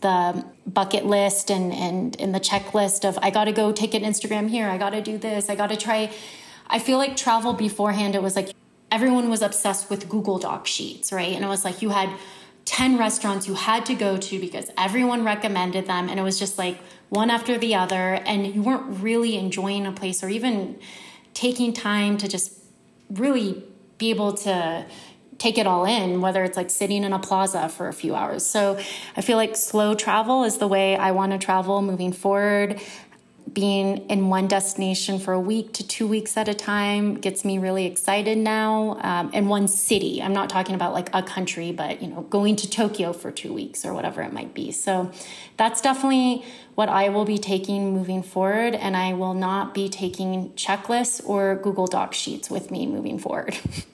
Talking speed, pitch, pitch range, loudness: 200 wpm, 200 Hz, 190-220 Hz, -23 LUFS